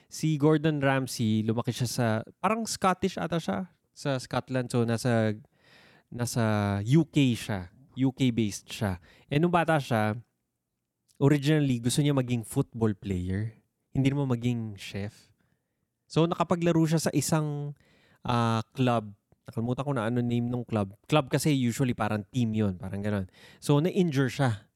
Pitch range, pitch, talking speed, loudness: 110-150 Hz, 125 Hz, 140 wpm, -28 LUFS